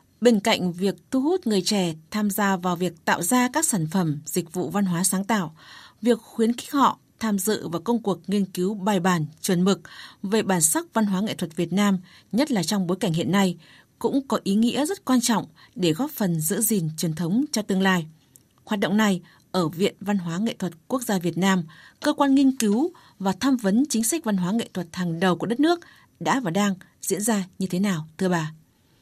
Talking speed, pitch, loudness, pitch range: 230 wpm, 195 Hz, -24 LUFS, 180-225 Hz